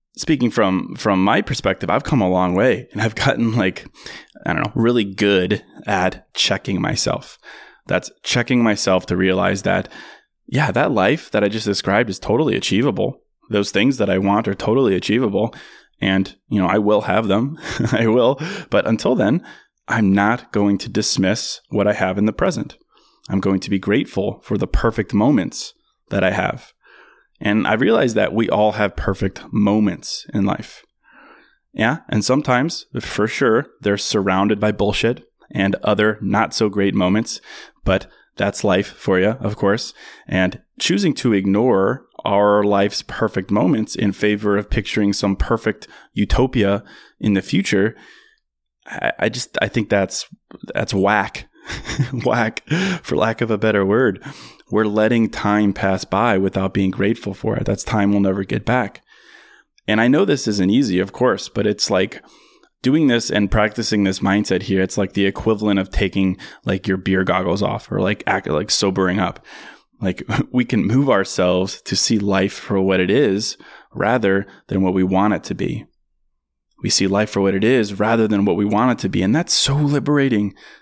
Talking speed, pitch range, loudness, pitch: 175 wpm, 95-110 Hz, -18 LUFS, 100 Hz